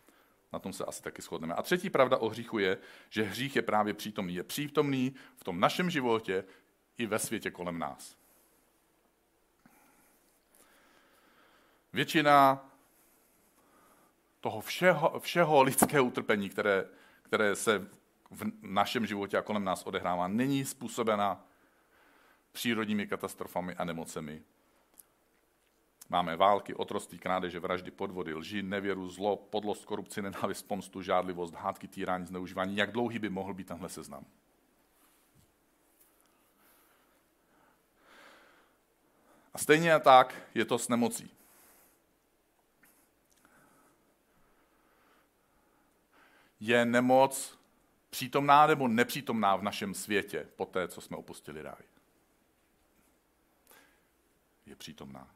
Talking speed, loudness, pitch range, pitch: 105 wpm, -31 LUFS, 95-135 Hz, 110 Hz